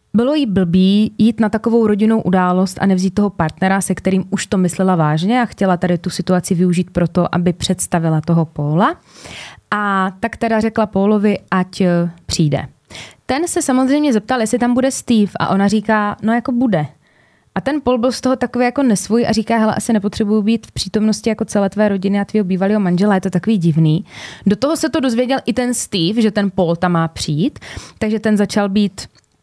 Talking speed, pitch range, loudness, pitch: 200 wpm, 185-230 Hz, -16 LUFS, 205 Hz